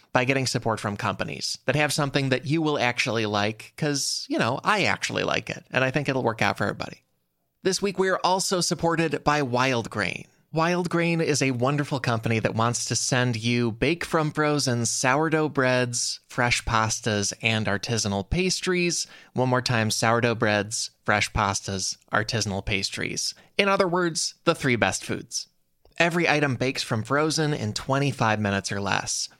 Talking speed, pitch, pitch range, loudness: 170 wpm, 125 Hz, 110-150 Hz, -24 LUFS